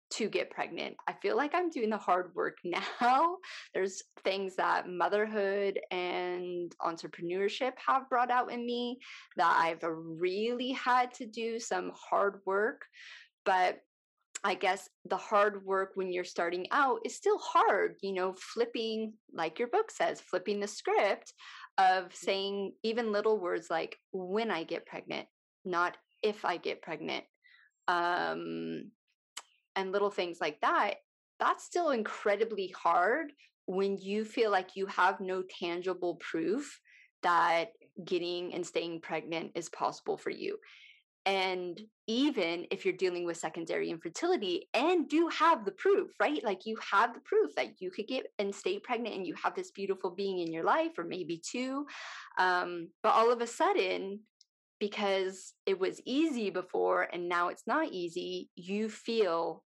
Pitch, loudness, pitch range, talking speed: 205 Hz, -33 LUFS, 180-260 Hz, 155 wpm